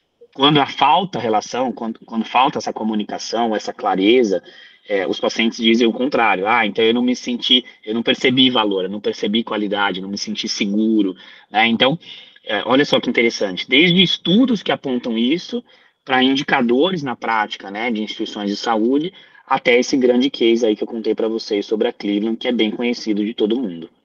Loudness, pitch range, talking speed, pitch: -18 LUFS, 105-125 Hz, 195 wpm, 115 Hz